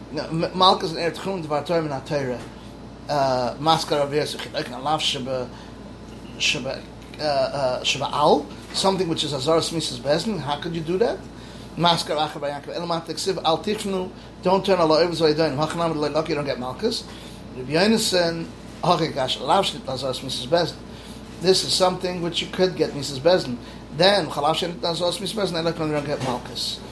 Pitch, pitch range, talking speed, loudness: 160 Hz, 145-180 Hz, 175 wpm, -23 LUFS